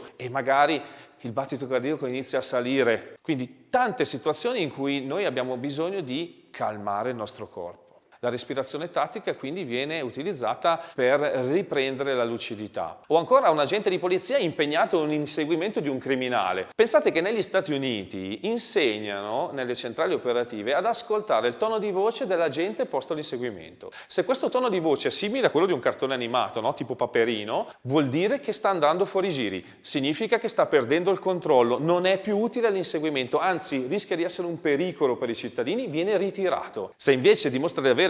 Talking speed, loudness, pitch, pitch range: 175 wpm, -25 LUFS, 160 Hz, 135-200 Hz